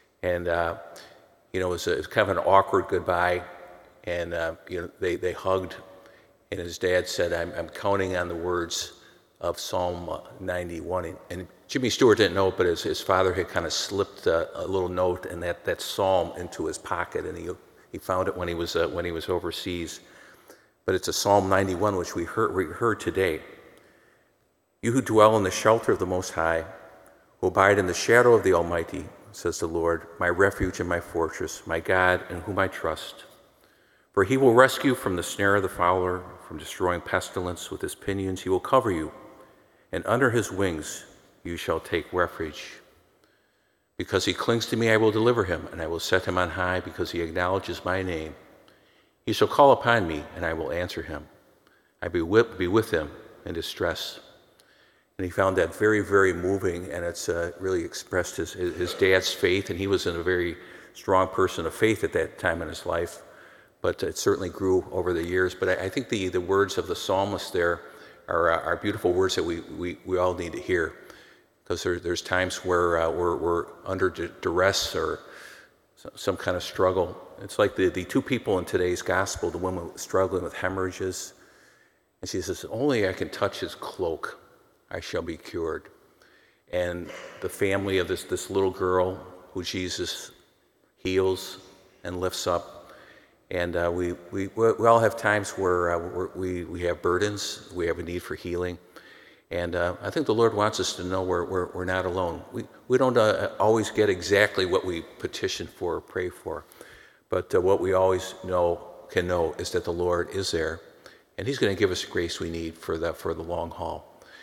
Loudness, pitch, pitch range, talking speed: -26 LUFS, 90 Hz, 90-100 Hz, 200 wpm